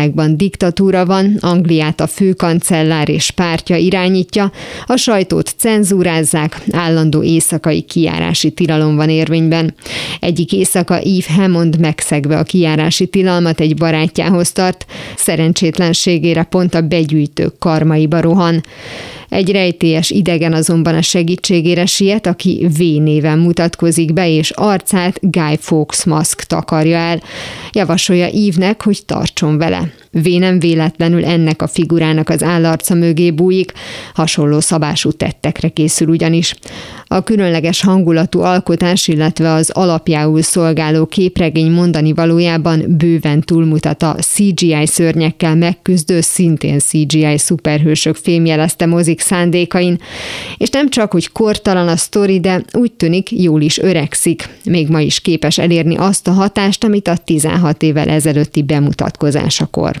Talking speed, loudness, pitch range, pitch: 120 wpm, -12 LUFS, 160-180 Hz, 170 Hz